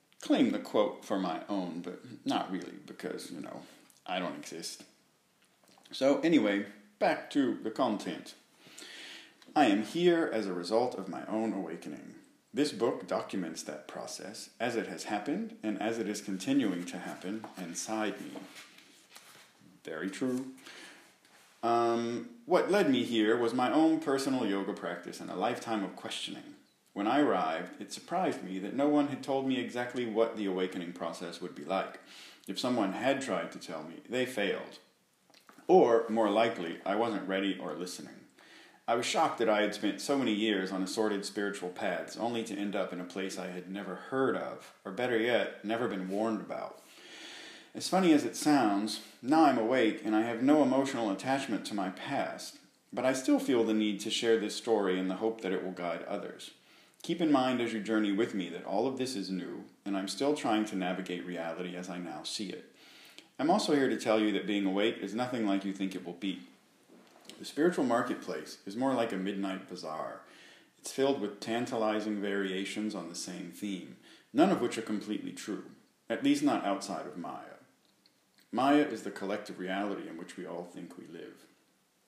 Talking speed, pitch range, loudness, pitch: 190 wpm, 95-130 Hz, -32 LUFS, 110 Hz